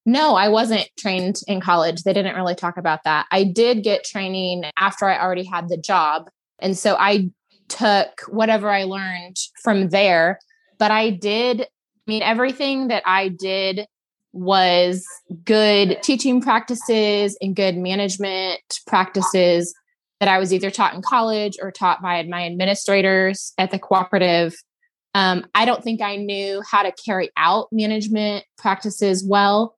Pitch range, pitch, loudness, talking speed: 185-215 Hz, 195 Hz, -19 LUFS, 155 wpm